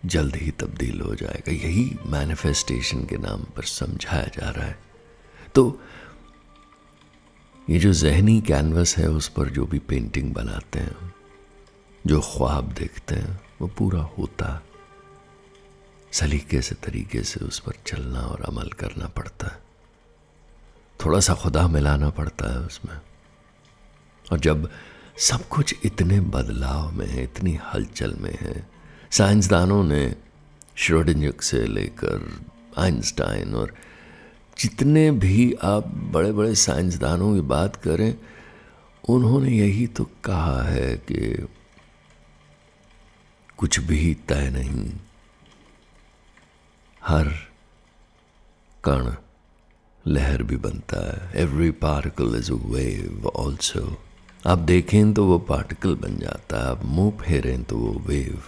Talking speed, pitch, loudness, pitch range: 120 wpm, 80 Hz, -23 LUFS, 75-95 Hz